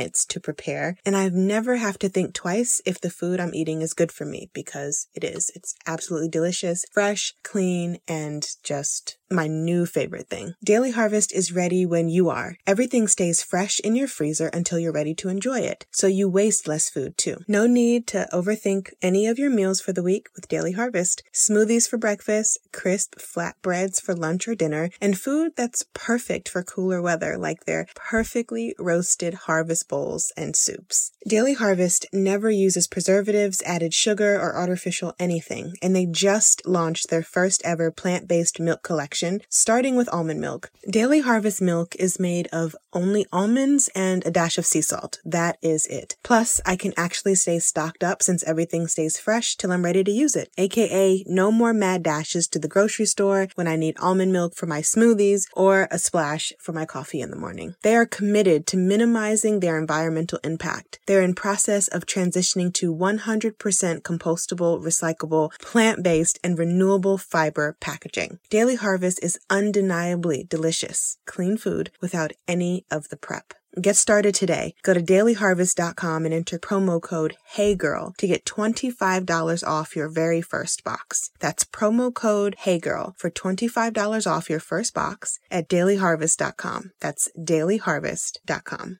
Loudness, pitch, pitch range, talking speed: -22 LUFS, 185 Hz, 170-205 Hz, 165 wpm